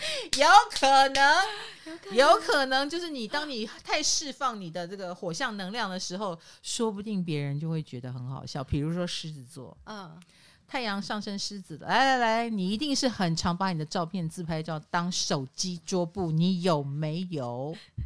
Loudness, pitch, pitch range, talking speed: -27 LUFS, 185 Hz, 165-240 Hz, 255 characters per minute